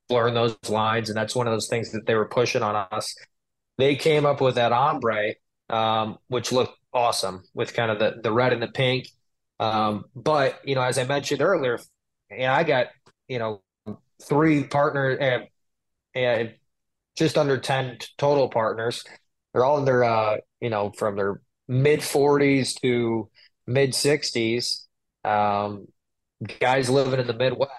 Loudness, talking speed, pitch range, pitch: -23 LUFS, 165 wpm, 110-140 Hz, 125 Hz